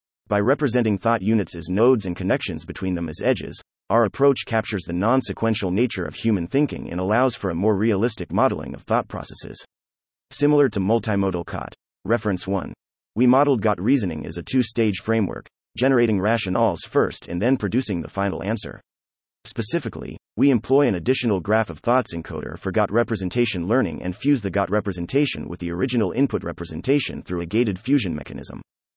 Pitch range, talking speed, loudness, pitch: 90-120 Hz, 175 wpm, -22 LUFS, 105 Hz